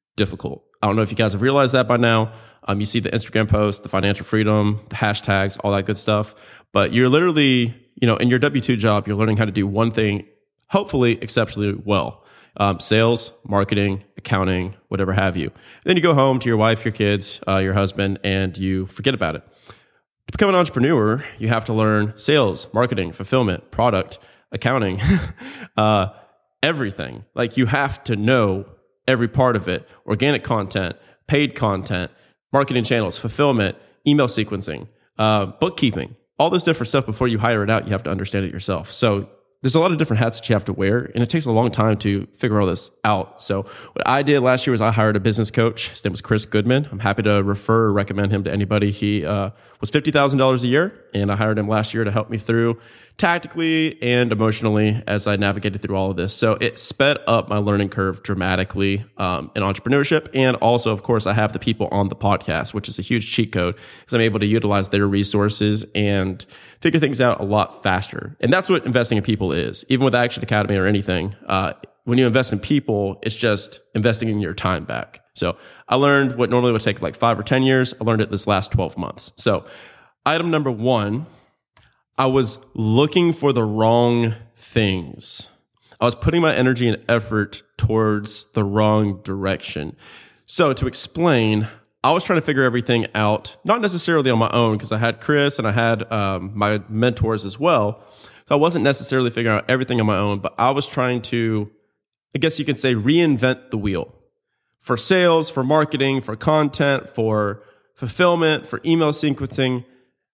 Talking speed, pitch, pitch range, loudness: 200 wpm, 110 Hz, 100-130 Hz, -20 LUFS